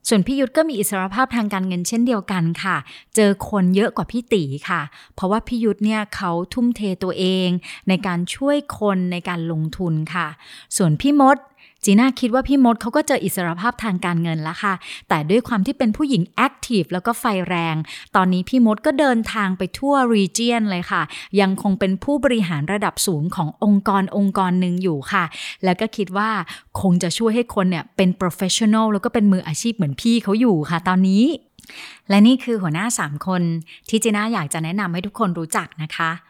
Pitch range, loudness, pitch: 180-230 Hz, -19 LUFS, 200 Hz